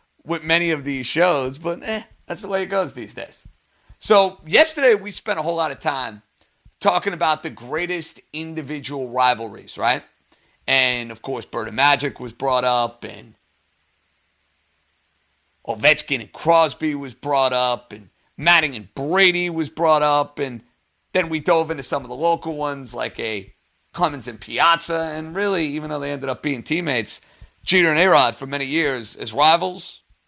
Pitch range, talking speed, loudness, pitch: 120-165 Hz, 170 wpm, -20 LUFS, 145 Hz